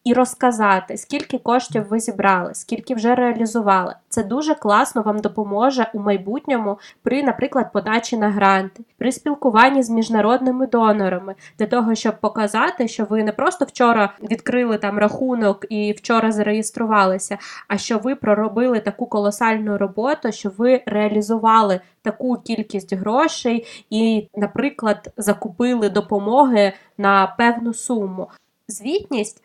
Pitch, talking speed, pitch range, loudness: 225 Hz, 125 wpm, 205-245 Hz, -19 LUFS